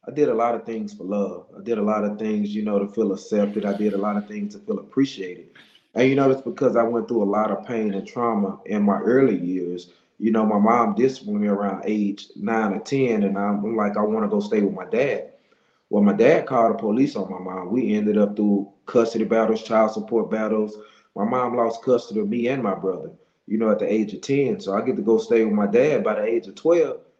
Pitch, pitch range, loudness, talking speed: 110 Hz, 105-120 Hz, -22 LUFS, 255 wpm